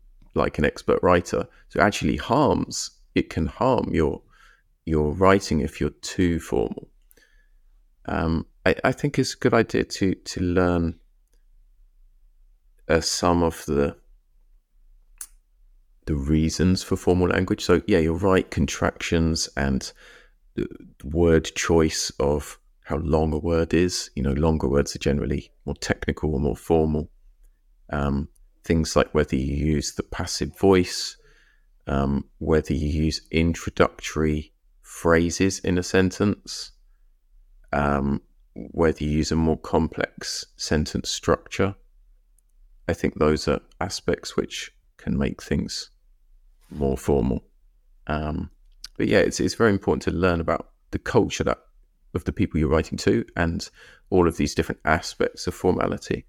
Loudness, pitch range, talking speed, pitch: -24 LUFS, 75-90 Hz, 135 wpm, 80 Hz